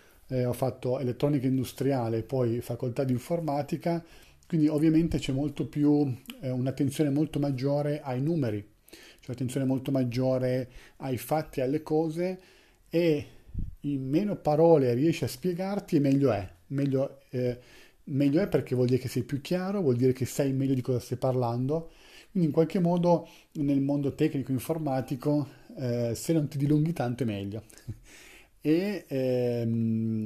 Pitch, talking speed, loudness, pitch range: 135 Hz, 150 wpm, -28 LUFS, 125-155 Hz